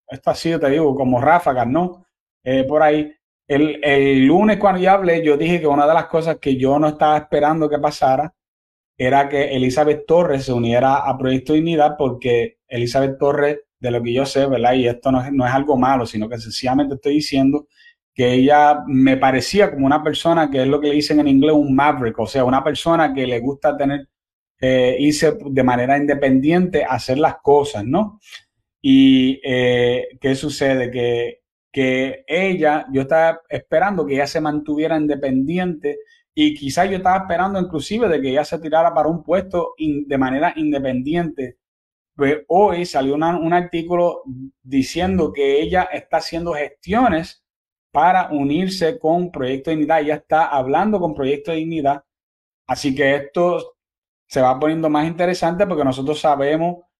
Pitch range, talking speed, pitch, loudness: 135-165 Hz, 175 wpm, 150 Hz, -17 LUFS